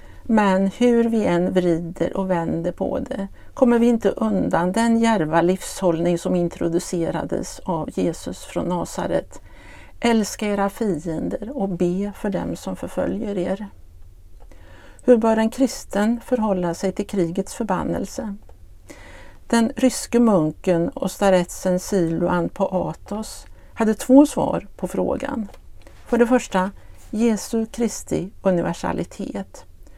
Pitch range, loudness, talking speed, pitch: 180-230 Hz, -21 LUFS, 120 wpm, 195 Hz